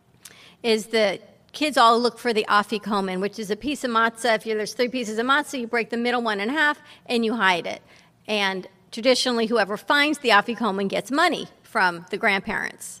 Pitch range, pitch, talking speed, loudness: 210-245 Hz, 225 Hz, 195 wpm, -22 LUFS